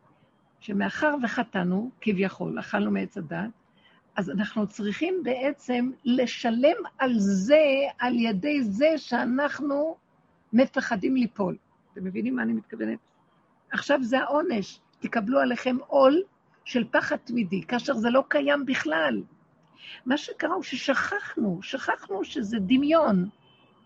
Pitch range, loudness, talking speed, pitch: 210-285 Hz, -26 LUFS, 115 wpm, 250 Hz